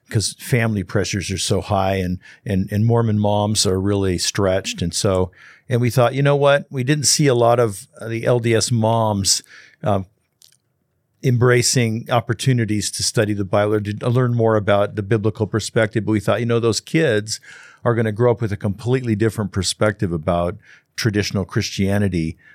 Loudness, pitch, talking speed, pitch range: -19 LUFS, 110 Hz, 175 wpm, 100-120 Hz